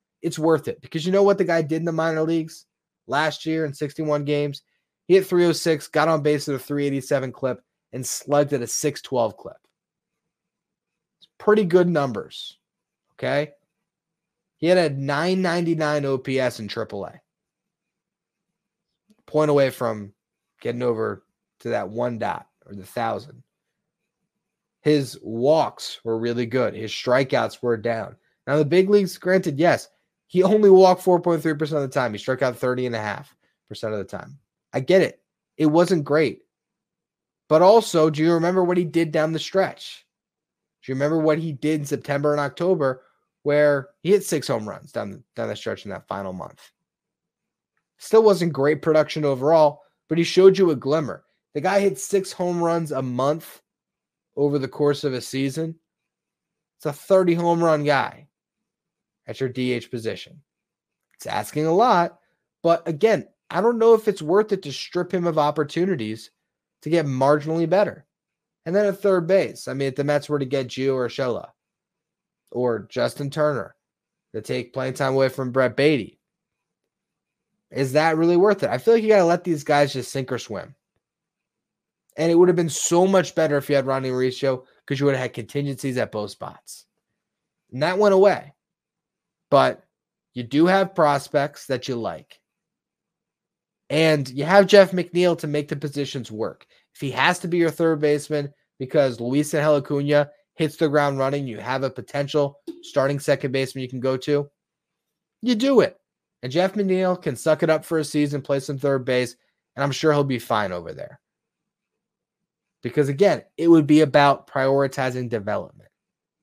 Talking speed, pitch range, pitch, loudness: 175 wpm, 135-175 Hz, 150 Hz, -21 LUFS